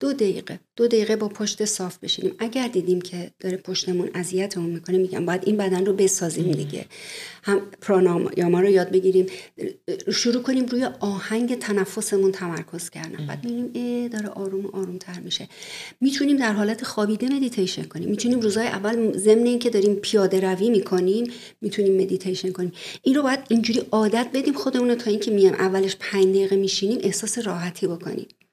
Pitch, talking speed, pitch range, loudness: 200 Hz, 165 wpm, 185-230 Hz, -23 LUFS